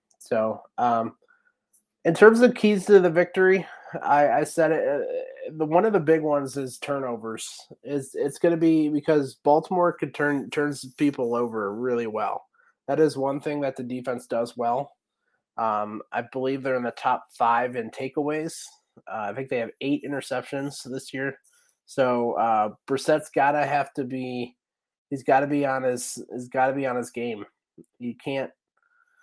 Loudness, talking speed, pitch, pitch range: -24 LUFS, 180 wpm, 140 Hz, 125-160 Hz